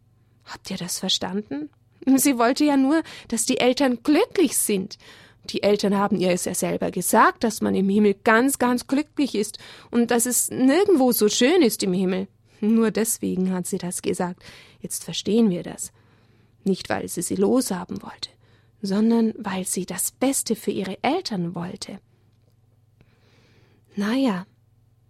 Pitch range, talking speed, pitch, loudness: 175-245 Hz, 155 wpm, 200 Hz, -22 LUFS